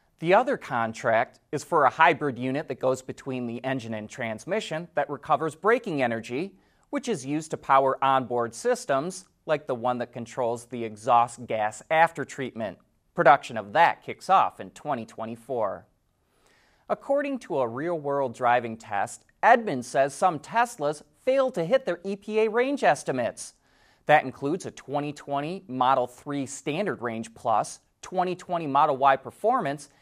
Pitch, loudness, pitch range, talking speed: 140 Hz, -26 LUFS, 125-175 Hz, 145 wpm